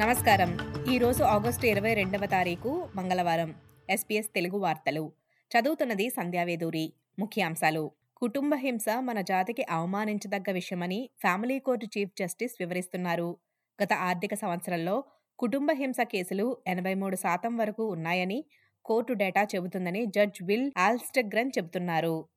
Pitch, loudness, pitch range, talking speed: 200 Hz, -29 LUFS, 180-235 Hz, 115 wpm